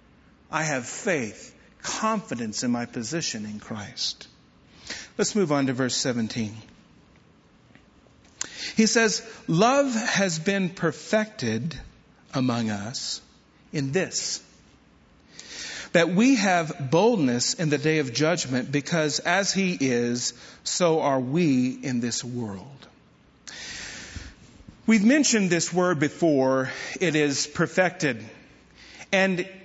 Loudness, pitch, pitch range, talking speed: -24 LUFS, 155 Hz, 125-190 Hz, 105 wpm